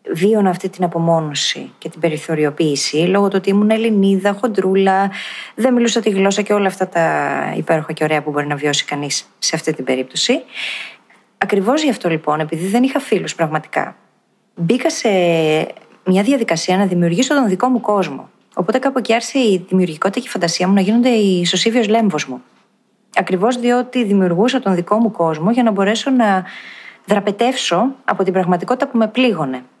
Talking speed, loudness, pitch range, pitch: 175 wpm, -16 LUFS, 165-230 Hz, 195 Hz